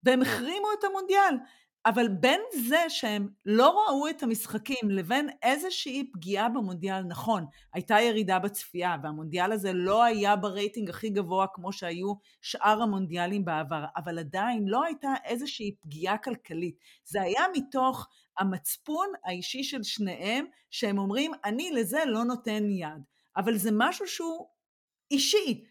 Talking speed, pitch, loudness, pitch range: 135 wpm, 220 Hz, -29 LUFS, 190-270 Hz